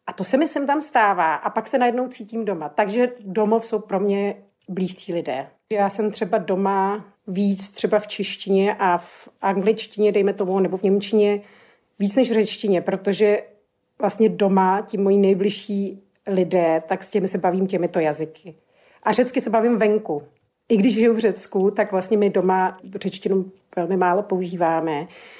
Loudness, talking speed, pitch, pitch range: -21 LUFS, 170 wpm, 200 Hz, 190-215 Hz